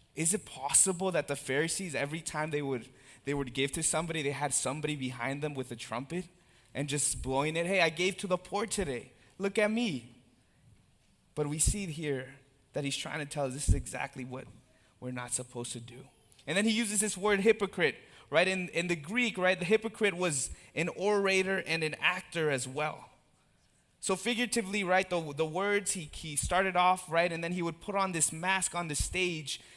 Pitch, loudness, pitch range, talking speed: 160 Hz, -31 LUFS, 135-190 Hz, 205 wpm